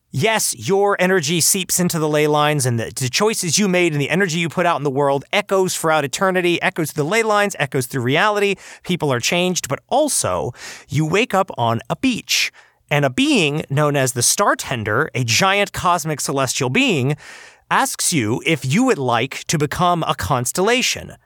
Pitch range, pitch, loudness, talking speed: 140-190 Hz, 160 Hz, -18 LUFS, 185 wpm